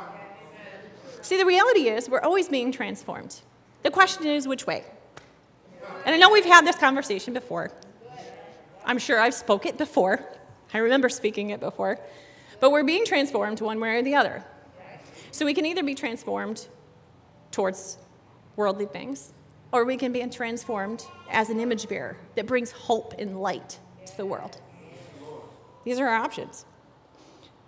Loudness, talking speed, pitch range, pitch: -24 LUFS, 155 wpm, 205-275 Hz, 240 Hz